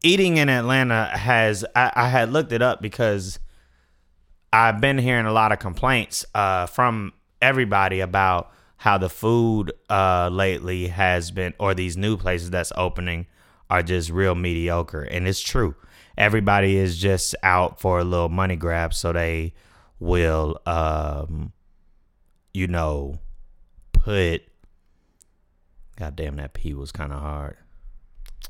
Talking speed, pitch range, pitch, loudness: 140 wpm, 80-100 Hz, 90 Hz, -22 LUFS